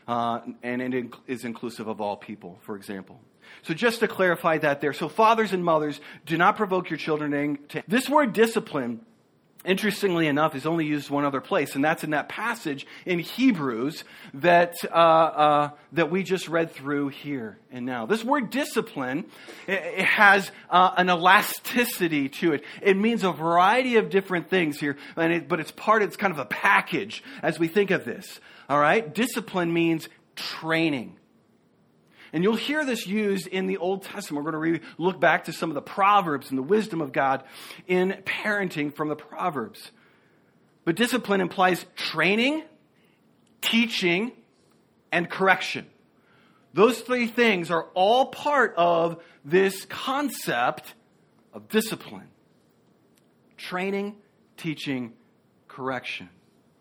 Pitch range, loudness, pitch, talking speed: 150-205 Hz, -24 LUFS, 175 Hz, 150 wpm